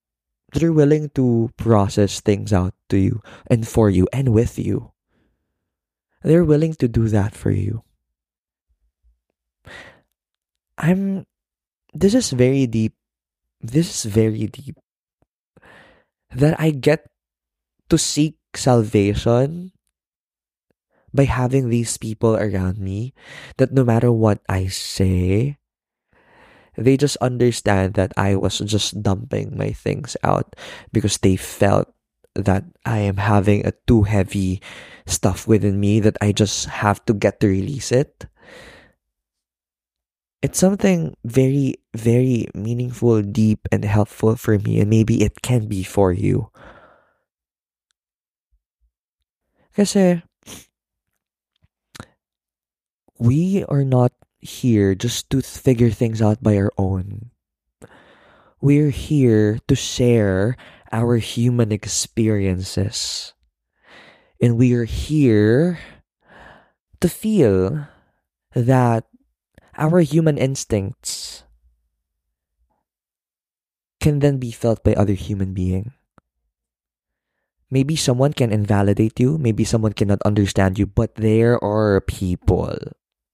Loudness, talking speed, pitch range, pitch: -19 LUFS, 110 wpm, 95-125 Hz, 110 Hz